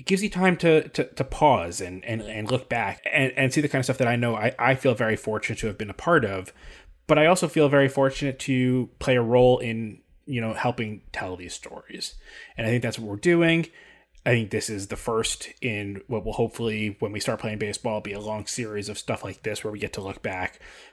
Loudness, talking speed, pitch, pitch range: -25 LUFS, 250 wpm, 115 Hz, 105-135 Hz